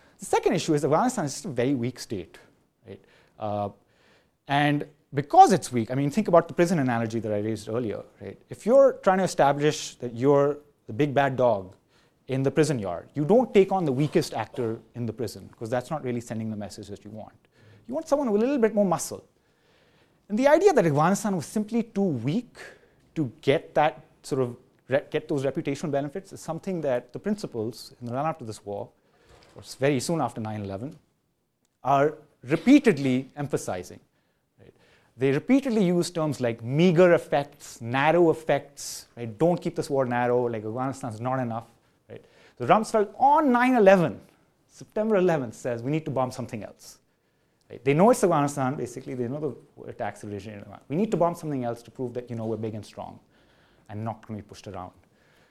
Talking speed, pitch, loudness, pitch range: 195 wpm, 140 Hz, -25 LUFS, 120-170 Hz